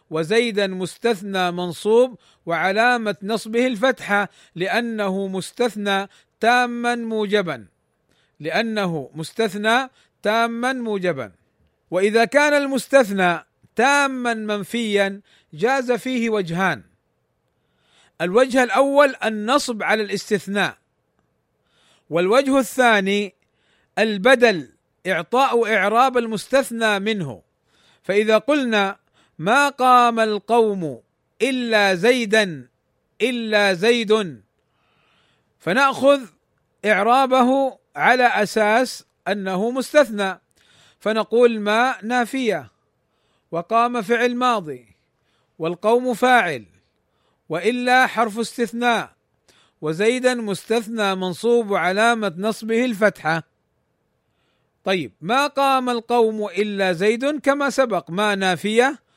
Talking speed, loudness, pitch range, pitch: 75 wpm, -19 LUFS, 195-245 Hz, 220 Hz